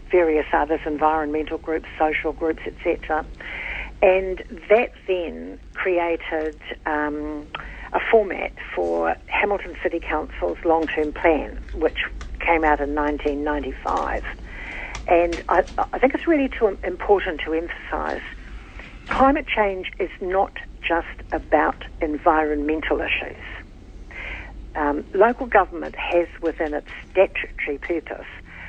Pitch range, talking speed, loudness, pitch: 150-185 Hz, 105 wpm, -23 LUFS, 160 Hz